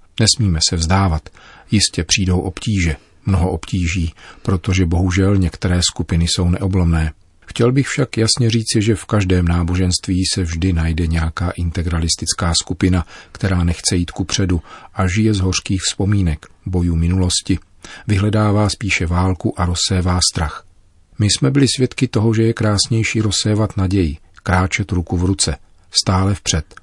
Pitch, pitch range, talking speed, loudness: 95 Hz, 85-105 Hz, 140 wpm, -17 LUFS